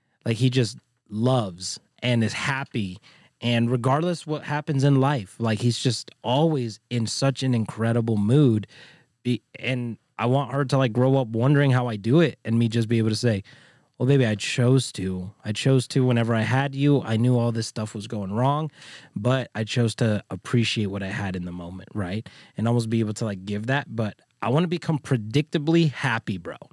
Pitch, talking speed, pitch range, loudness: 120 Hz, 200 wpm, 110-135 Hz, -24 LUFS